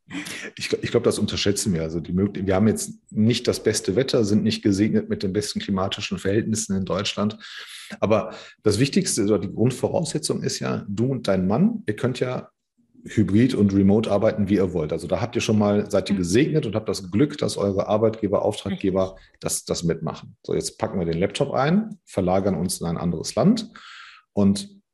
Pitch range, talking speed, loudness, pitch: 100-135 Hz, 195 wpm, -23 LUFS, 105 Hz